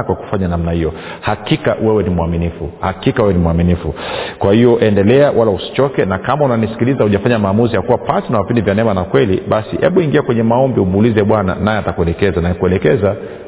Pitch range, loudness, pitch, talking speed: 85-115 Hz, -14 LUFS, 100 Hz, 185 wpm